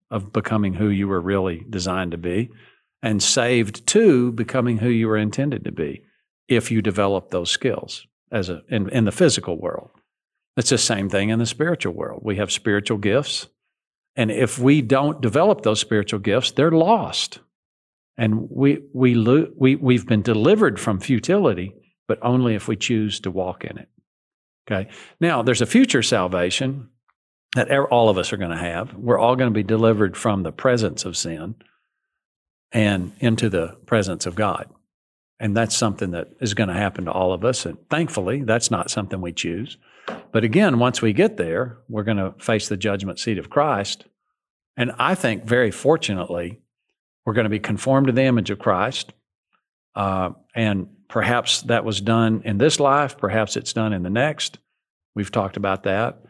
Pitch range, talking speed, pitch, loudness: 100-125 Hz, 180 wpm, 110 Hz, -21 LUFS